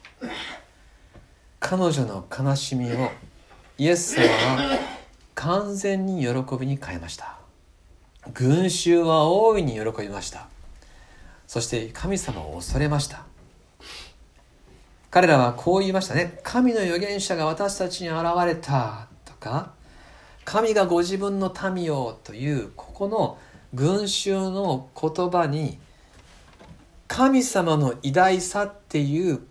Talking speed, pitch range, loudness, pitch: 205 characters per minute, 125-190 Hz, -23 LUFS, 155 Hz